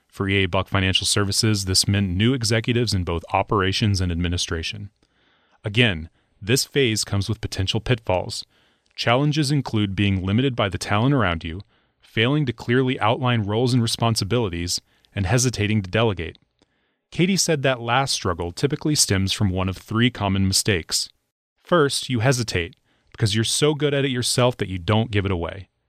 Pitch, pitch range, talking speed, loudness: 110 Hz, 95-125 Hz, 160 wpm, -21 LUFS